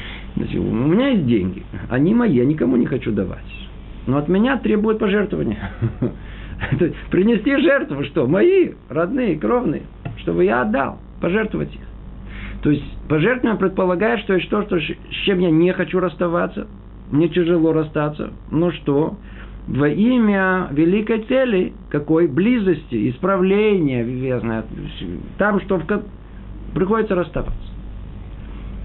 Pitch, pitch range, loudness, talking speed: 175 Hz, 125-200 Hz, -19 LUFS, 125 wpm